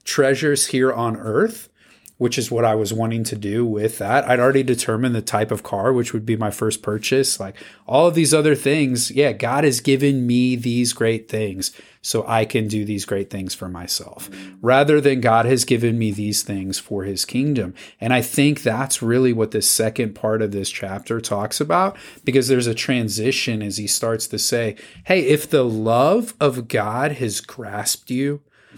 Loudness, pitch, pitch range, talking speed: -19 LUFS, 115 Hz, 110-135 Hz, 195 wpm